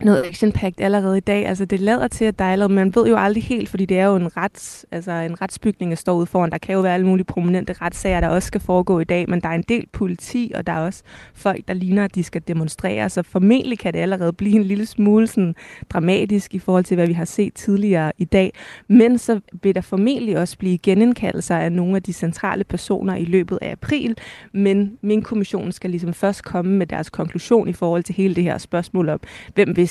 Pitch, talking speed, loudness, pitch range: 190 Hz, 240 wpm, -19 LUFS, 175-205 Hz